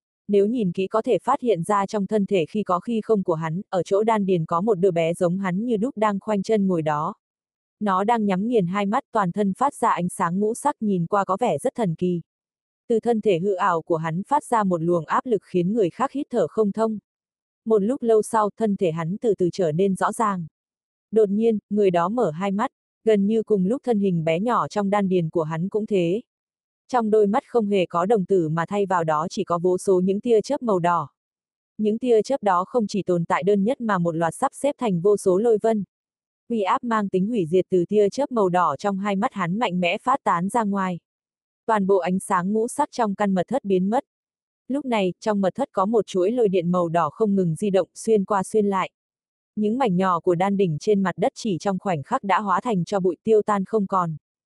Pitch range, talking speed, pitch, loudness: 180-220 Hz, 250 wpm, 200 Hz, -22 LUFS